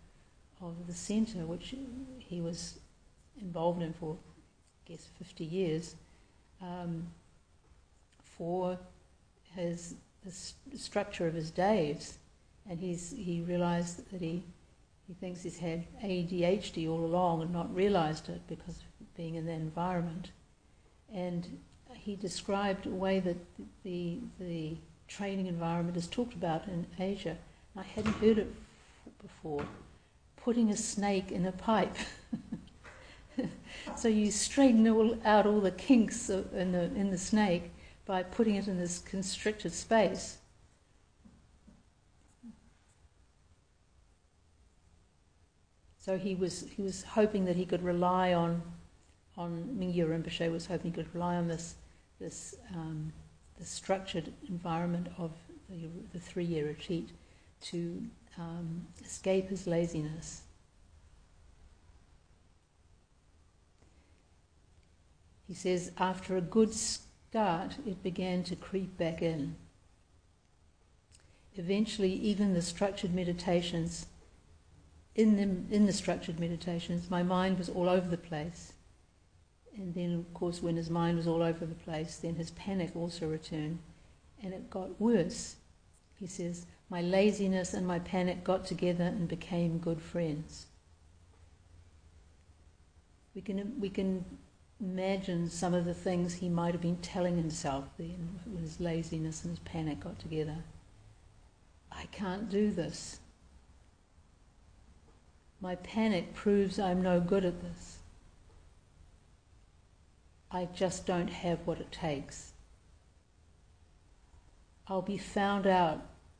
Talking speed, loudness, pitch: 125 wpm, -34 LUFS, 170 Hz